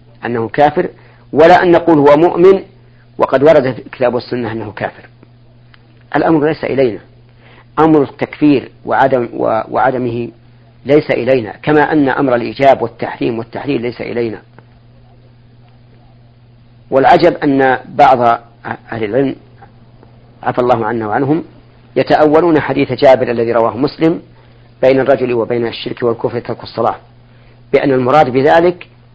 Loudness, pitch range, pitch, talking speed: -12 LUFS, 120-140 Hz, 120 Hz, 115 wpm